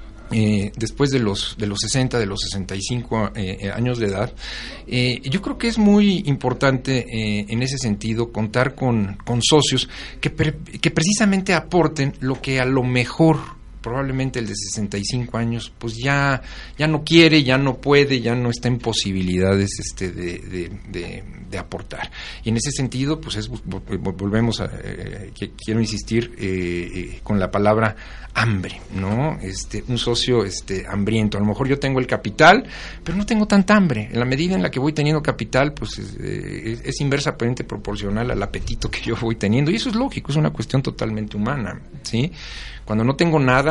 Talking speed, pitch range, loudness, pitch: 185 wpm, 105-135 Hz, -20 LUFS, 120 Hz